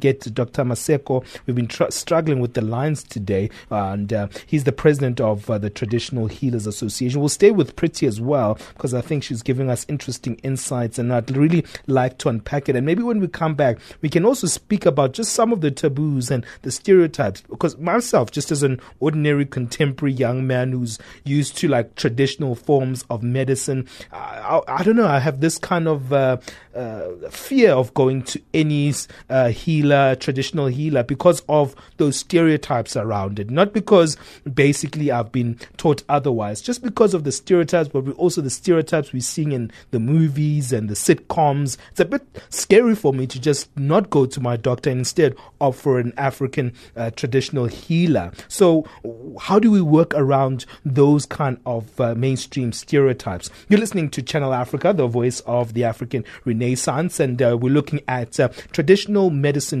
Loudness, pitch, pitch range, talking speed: -20 LUFS, 140 Hz, 125-155 Hz, 185 wpm